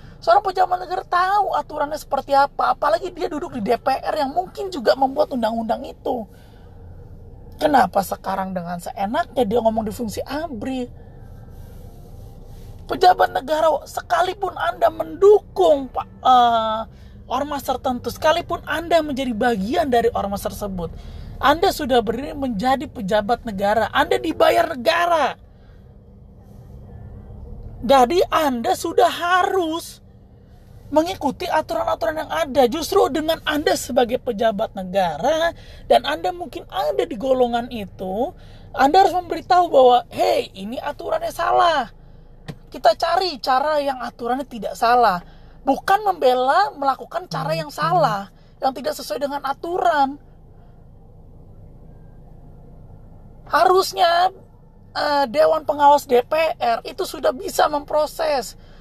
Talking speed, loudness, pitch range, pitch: 110 wpm, -20 LUFS, 235-335 Hz, 280 Hz